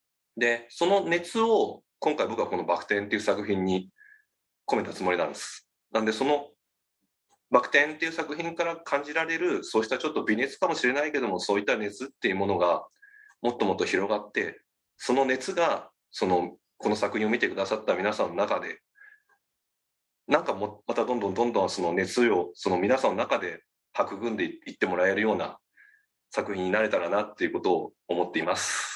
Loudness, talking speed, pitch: -27 LUFS, 375 characters per minute, 170 Hz